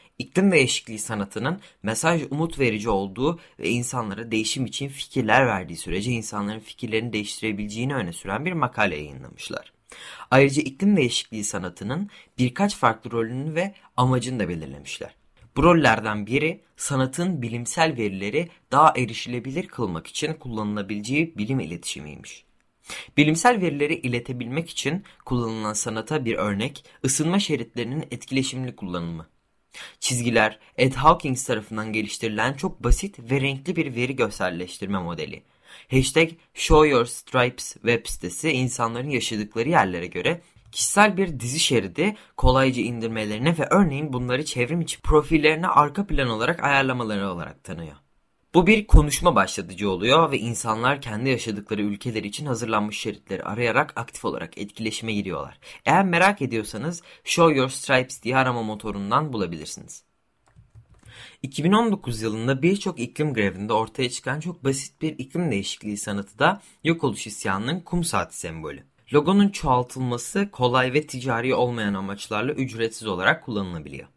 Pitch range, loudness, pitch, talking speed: 110-155 Hz, -23 LUFS, 125 Hz, 125 wpm